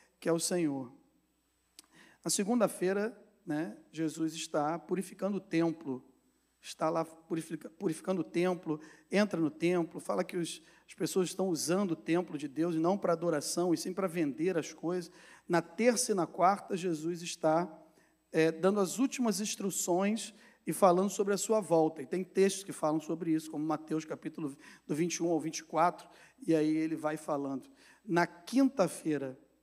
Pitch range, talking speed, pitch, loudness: 160-190 Hz, 160 wpm, 170 Hz, -33 LUFS